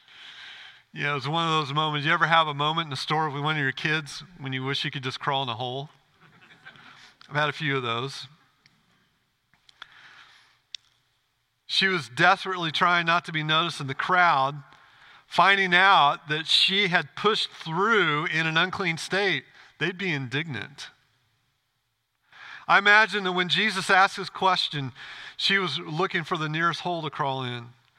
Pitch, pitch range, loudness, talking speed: 155 Hz, 135-180 Hz, -23 LUFS, 170 wpm